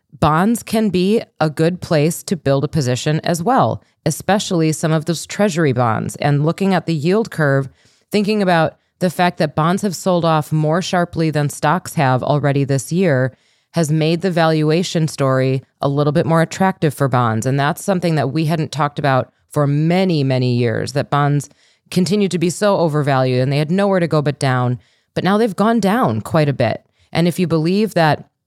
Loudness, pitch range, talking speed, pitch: -17 LUFS, 145-180 Hz, 195 wpm, 160 Hz